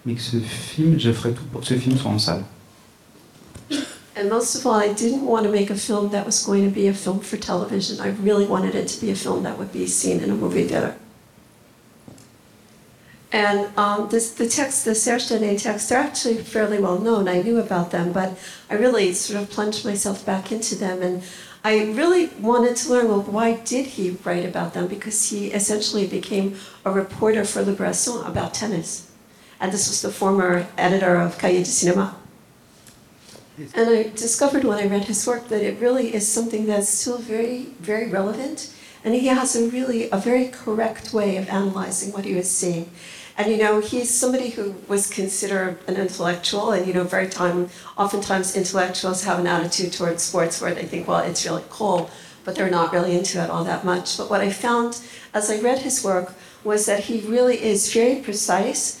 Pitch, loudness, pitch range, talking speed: 205 Hz, -21 LUFS, 185-230 Hz, 195 wpm